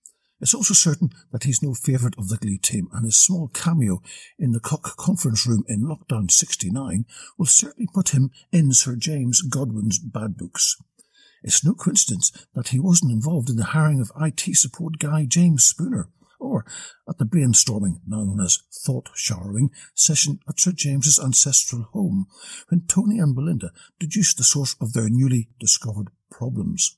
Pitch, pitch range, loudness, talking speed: 140 Hz, 115-165 Hz, -19 LUFS, 170 wpm